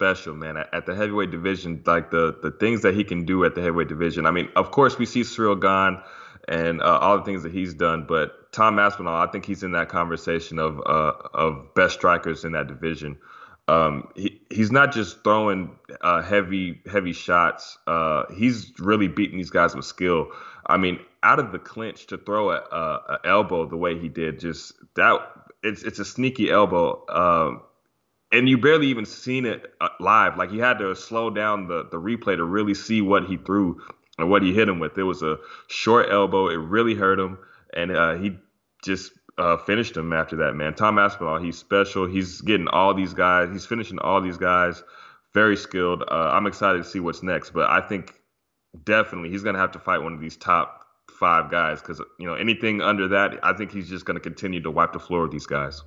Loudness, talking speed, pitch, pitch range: -22 LUFS, 215 wpm, 95 Hz, 85-105 Hz